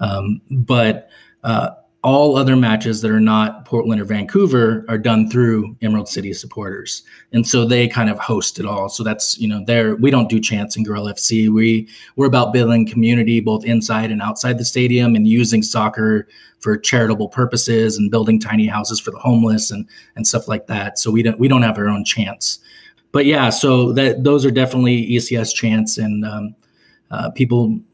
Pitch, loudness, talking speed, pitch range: 110 Hz, -16 LUFS, 190 wpm, 110-120 Hz